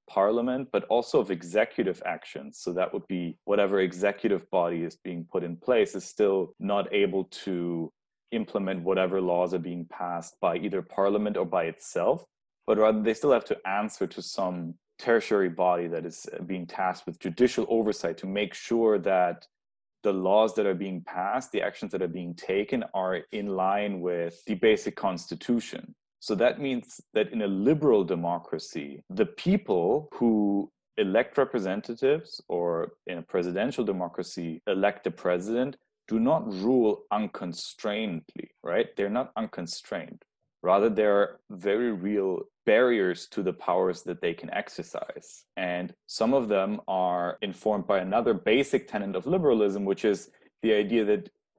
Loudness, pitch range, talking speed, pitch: -28 LUFS, 90-105 Hz, 155 wpm, 95 Hz